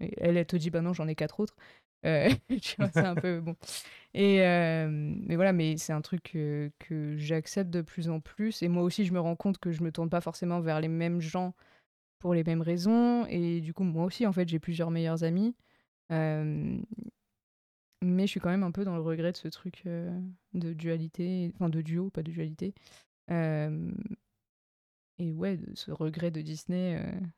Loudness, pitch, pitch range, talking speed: -31 LUFS, 170 Hz, 160-185 Hz, 205 wpm